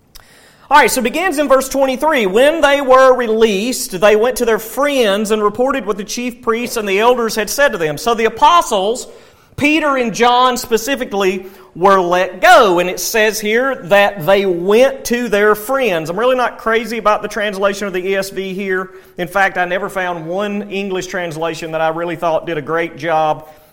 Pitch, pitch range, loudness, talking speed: 210 Hz, 185-245 Hz, -14 LUFS, 190 wpm